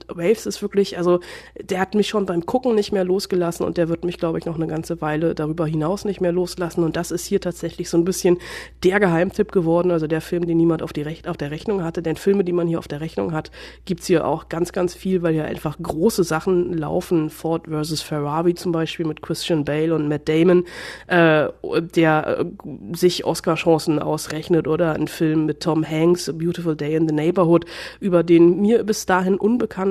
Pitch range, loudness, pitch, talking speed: 160-180 Hz, -20 LUFS, 170 Hz, 215 wpm